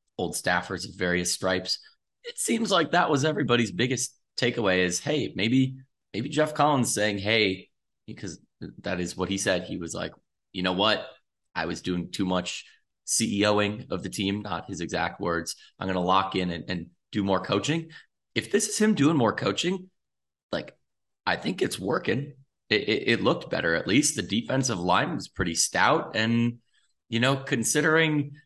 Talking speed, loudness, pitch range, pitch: 180 wpm, -26 LUFS, 95-145 Hz, 105 Hz